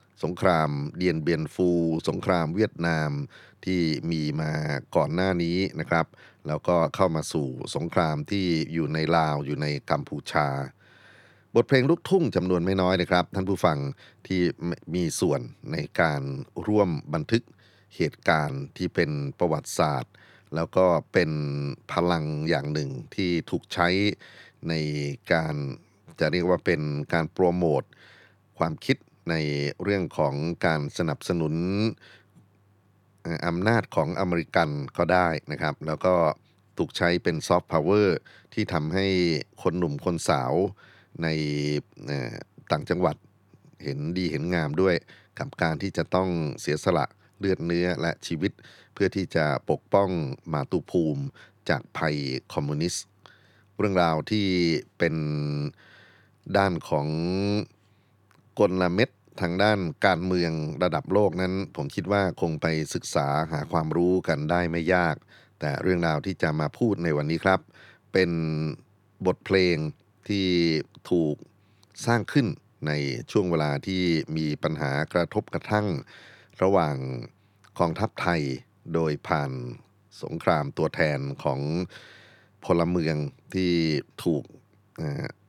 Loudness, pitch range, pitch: -26 LUFS, 75-95 Hz, 85 Hz